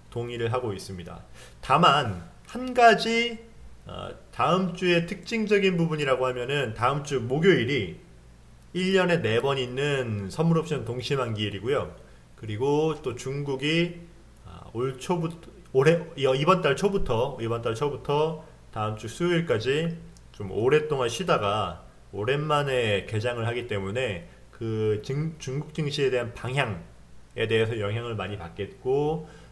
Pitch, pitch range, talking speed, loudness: 135 Hz, 110-165 Hz, 265 characters per minute, -26 LUFS